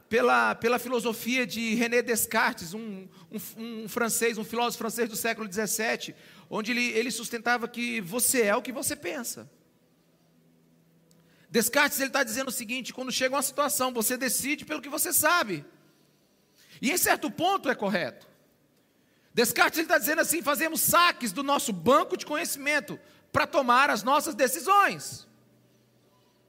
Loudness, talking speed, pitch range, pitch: -26 LUFS, 150 wpm, 225-290 Hz, 245 Hz